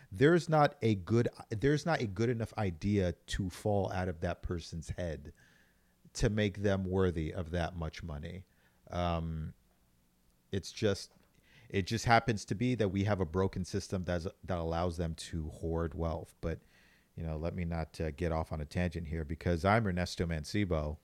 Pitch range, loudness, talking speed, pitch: 80-105 Hz, -34 LUFS, 180 wpm, 90 Hz